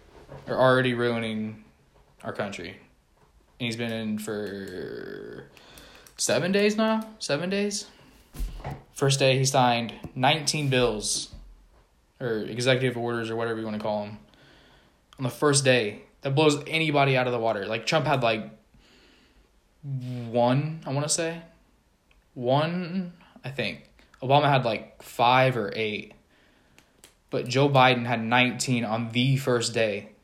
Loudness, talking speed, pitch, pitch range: -25 LUFS, 135 wpm, 125 Hz, 110-140 Hz